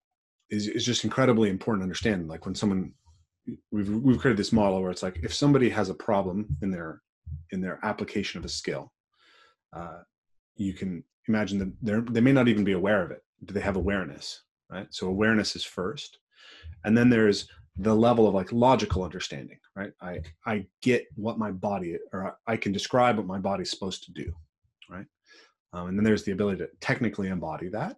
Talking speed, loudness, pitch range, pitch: 195 wpm, -27 LUFS, 90-110 Hz, 100 Hz